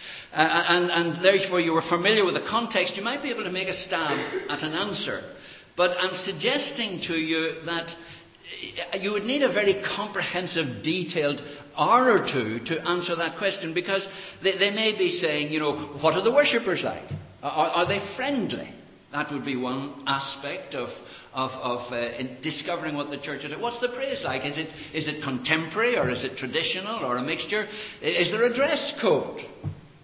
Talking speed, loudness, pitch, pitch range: 190 wpm, -25 LUFS, 175 Hz, 150-200 Hz